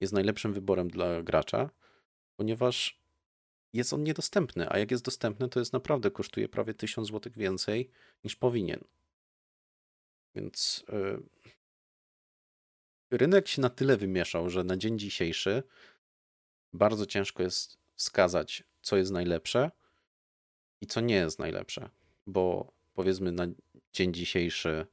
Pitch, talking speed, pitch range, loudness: 95 Hz, 125 wpm, 90-115 Hz, -31 LUFS